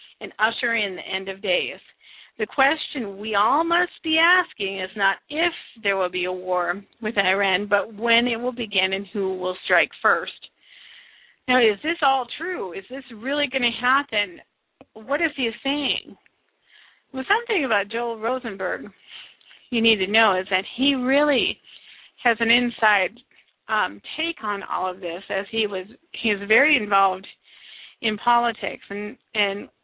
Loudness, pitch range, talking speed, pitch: -22 LUFS, 200-265 Hz, 165 wpm, 225 Hz